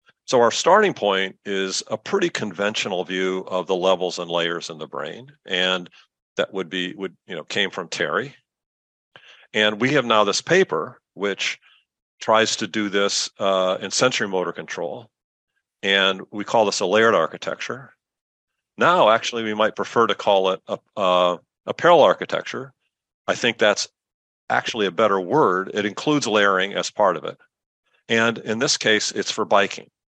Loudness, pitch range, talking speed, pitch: -21 LUFS, 95-110 Hz, 165 wpm, 95 Hz